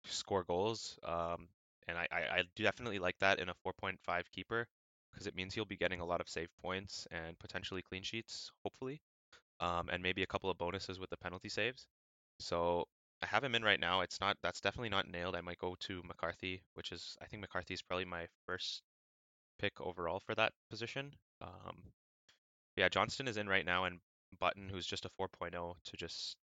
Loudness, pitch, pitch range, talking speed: -40 LUFS, 95 Hz, 85-100 Hz, 200 wpm